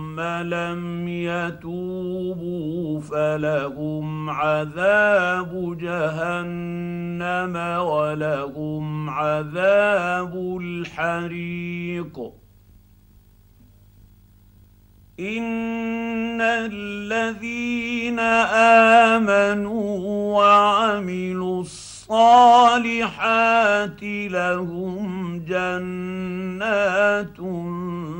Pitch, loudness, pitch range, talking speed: 180 Hz, -21 LUFS, 160-205 Hz, 35 wpm